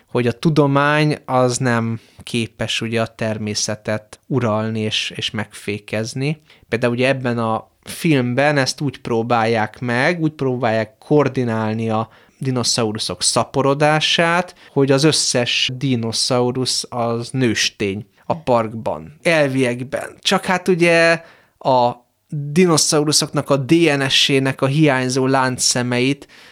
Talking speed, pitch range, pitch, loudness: 105 wpm, 115-145 Hz, 125 Hz, -18 LUFS